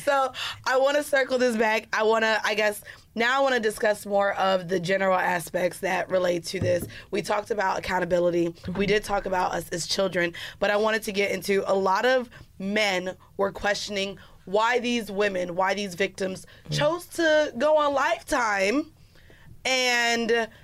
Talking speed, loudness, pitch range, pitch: 175 wpm, -25 LUFS, 190-235 Hz, 205 Hz